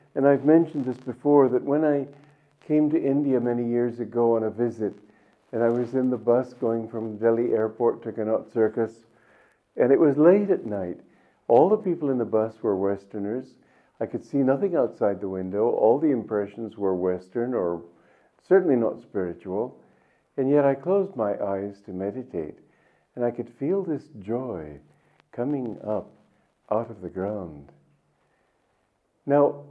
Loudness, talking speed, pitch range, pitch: -25 LUFS, 165 wpm, 105-140 Hz, 120 Hz